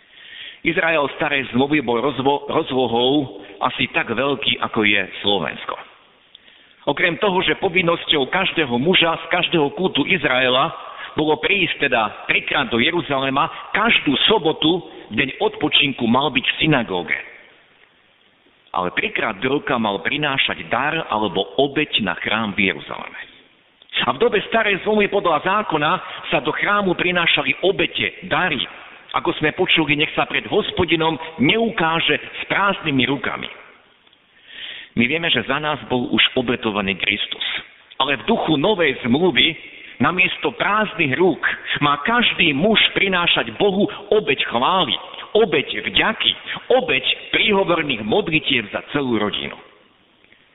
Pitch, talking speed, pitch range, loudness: 155 Hz, 125 wpm, 135-185 Hz, -18 LUFS